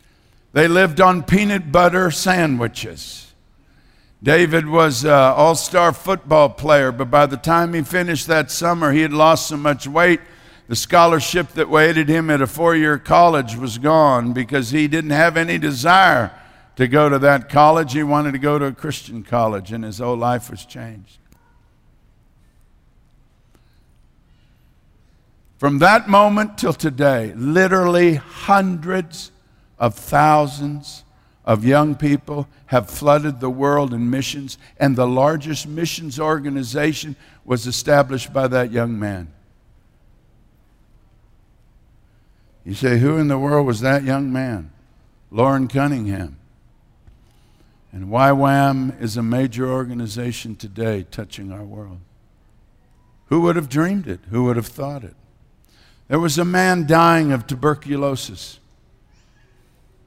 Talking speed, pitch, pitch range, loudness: 130 wpm, 140 Hz, 120-155 Hz, -17 LUFS